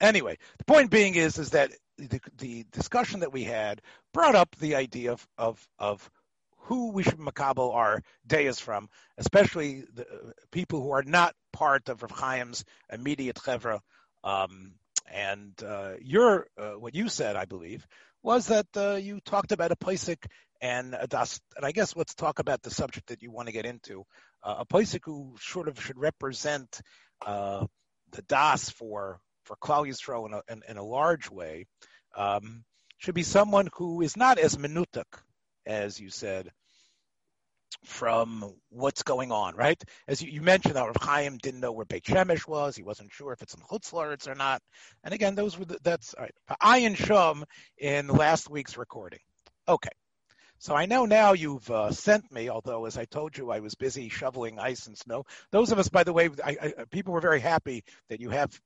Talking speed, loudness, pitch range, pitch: 190 wpm, -28 LUFS, 115-175 Hz, 140 Hz